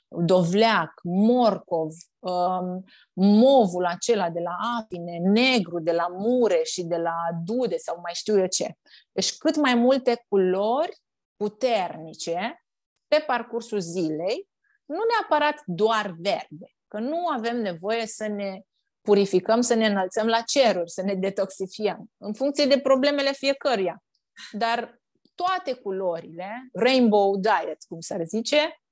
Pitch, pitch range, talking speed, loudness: 215 Hz, 185-255 Hz, 130 wpm, -24 LUFS